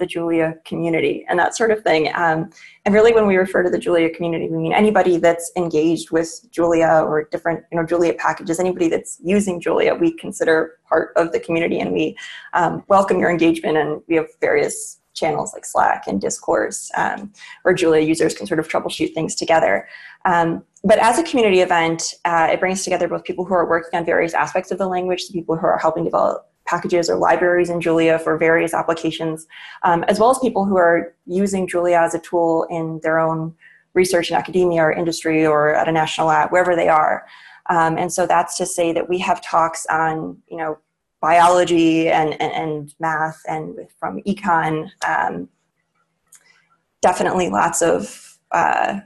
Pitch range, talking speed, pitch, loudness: 160-180 Hz, 190 wpm, 170 Hz, -18 LUFS